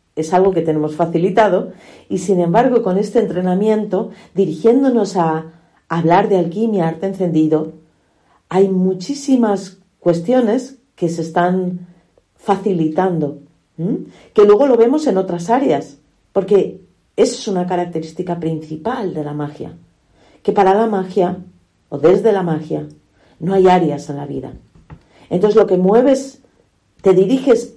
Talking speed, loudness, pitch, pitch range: 135 wpm, -16 LUFS, 185 Hz, 165-215 Hz